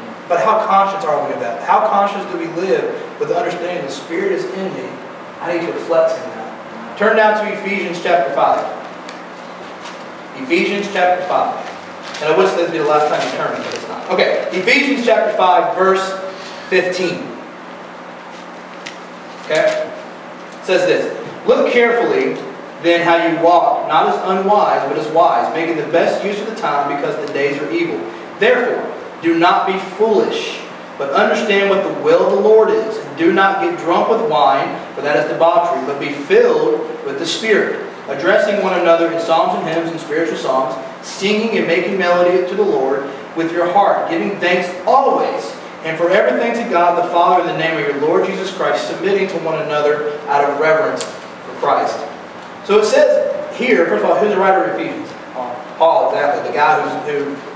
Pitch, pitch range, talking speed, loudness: 190 Hz, 165-260 Hz, 190 wpm, -15 LUFS